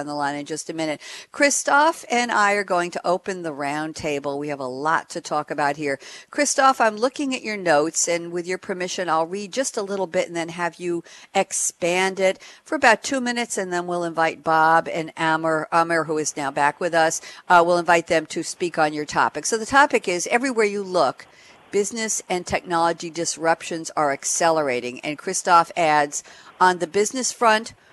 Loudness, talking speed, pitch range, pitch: -21 LUFS, 200 wpm, 160-200 Hz, 175 Hz